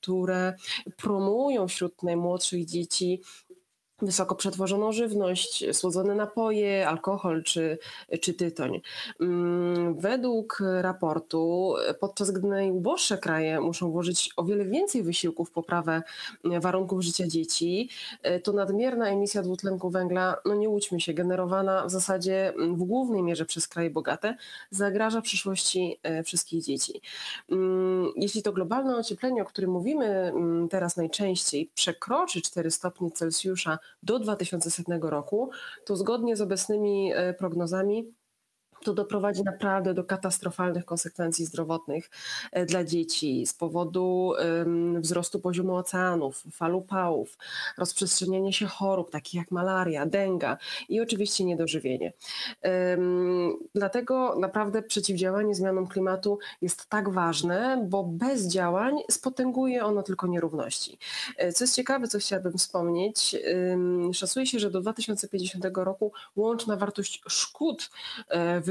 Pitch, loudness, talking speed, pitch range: 185 Hz, -28 LUFS, 115 wpm, 175-205 Hz